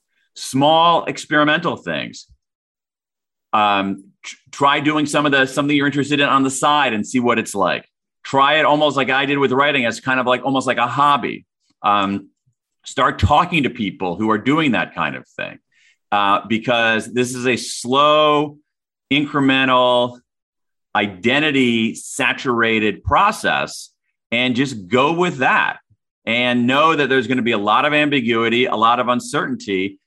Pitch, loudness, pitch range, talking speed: 130 Hz, -17 LUFS, 115-145 Hz, 160 wpm